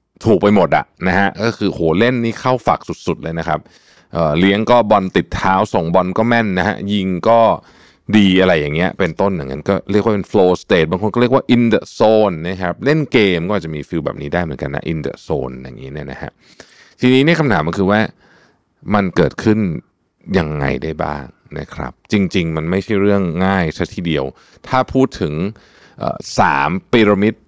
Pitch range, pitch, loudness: 85-110 Hz, 95 Hz, -16 LUFS